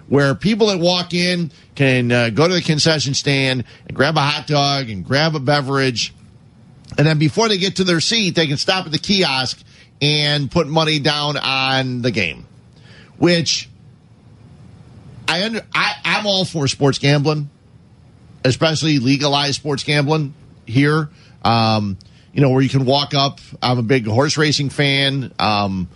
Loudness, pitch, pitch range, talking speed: -17 LUFS, 140 Hz, 130-155 Hz, 165 wpm